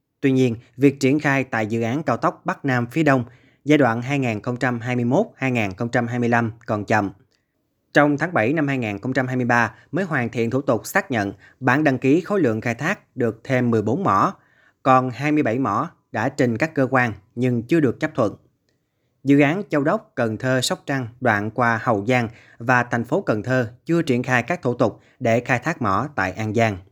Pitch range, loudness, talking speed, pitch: 115-140 Hz, -21 LUFS, 190 wpm, 125 Hz